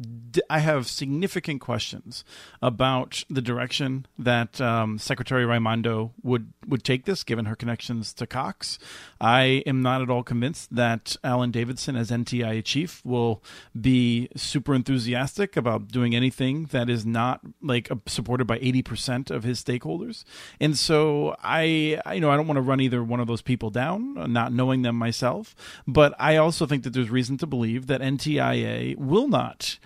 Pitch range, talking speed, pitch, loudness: 120-140 Hz, 165 wpm, 125 Hz, -25 LUFS